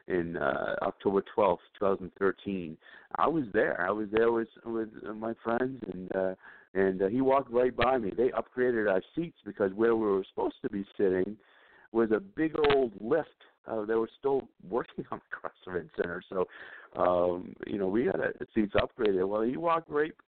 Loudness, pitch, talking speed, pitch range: -30 LUFS, 110 Hz, 195 wpm, 95-125 Hz